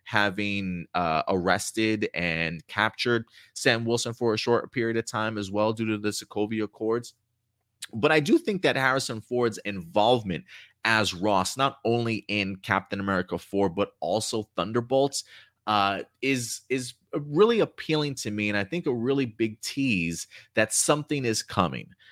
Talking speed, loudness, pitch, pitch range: 155 wpm, -26 LUFS, 110 Hz, 100-130 Hz